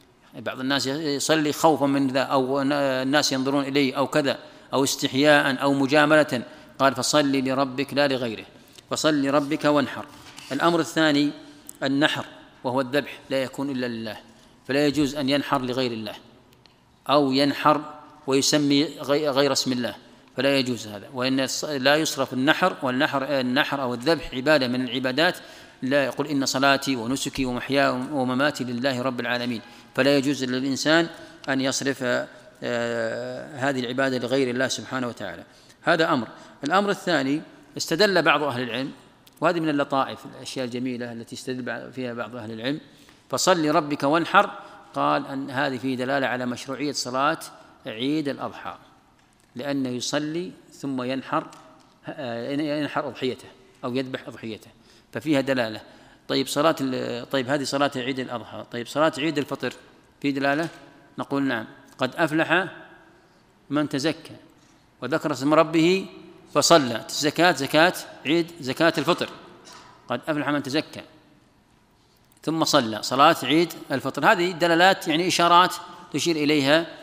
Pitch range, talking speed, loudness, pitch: 130-150 Hz, 130 wpm, -23 LUFS, 140 Hz